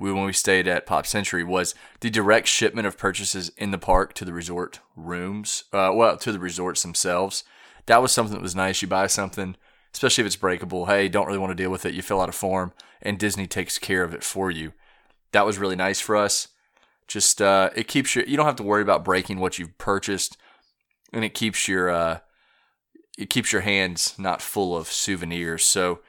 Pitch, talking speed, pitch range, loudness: 95 Hz, 215 wpm, 90-100 Hz, -23 LUFS